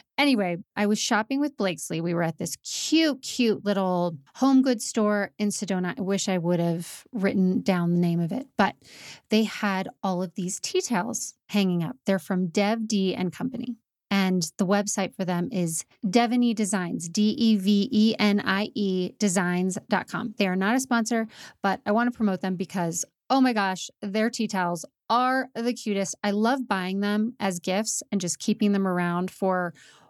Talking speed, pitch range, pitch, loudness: 175 wpm, 185-225 Hz, 200 Hz, -26 LUFS